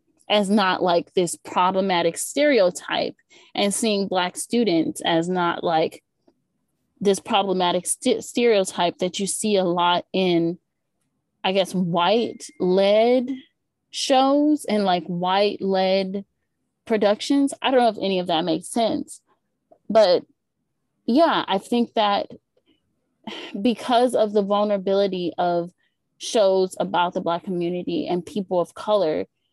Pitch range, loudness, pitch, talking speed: 180-235 Hz, -21 LUFS, 195 Hz, 125 wpm